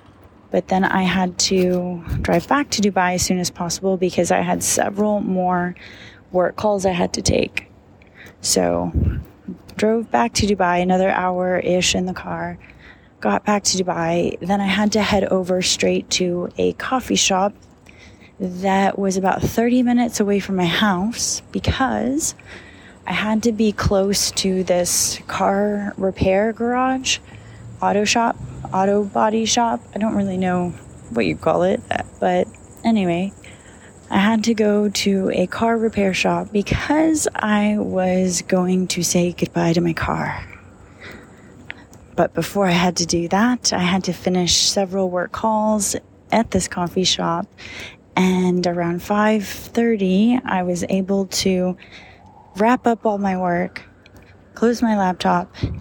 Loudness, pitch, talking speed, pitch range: -19 LUFS, 185 Hz, 145 wpm, 175-210 Hz